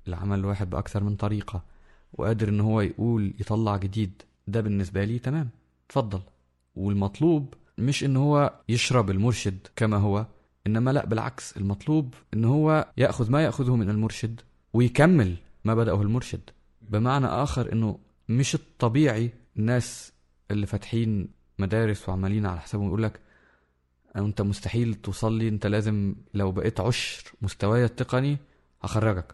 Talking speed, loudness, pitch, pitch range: 130 wpm, -26 LUFS, 110 Hz, 100-120 Hz